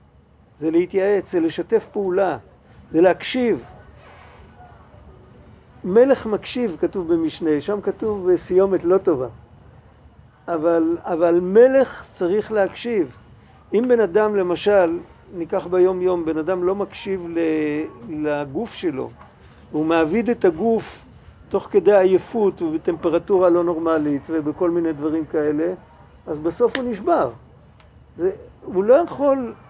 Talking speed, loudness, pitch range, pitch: 115 wpm, -20 LUFS, 165-220 Hz, 185 Hz